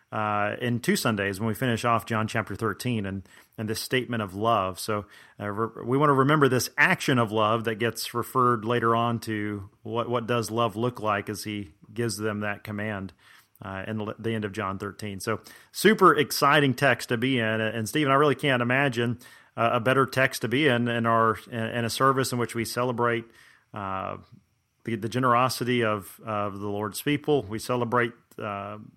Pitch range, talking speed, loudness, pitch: 105-125 Hz, 205 wpm, -26 LUFS, 115 Hz